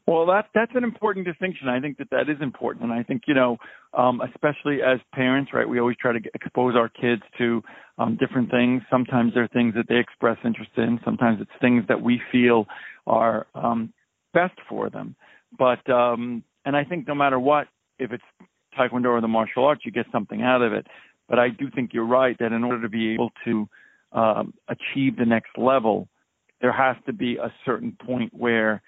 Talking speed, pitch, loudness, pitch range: 210 wpm, 125 Hz, -23 LUFS, 115-130 Hz